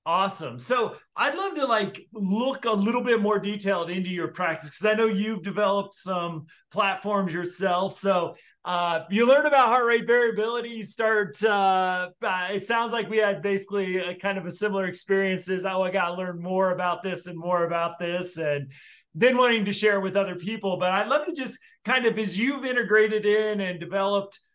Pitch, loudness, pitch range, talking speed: 200 Hz, -25 LUFS, 180-220 Hz, 200 wpm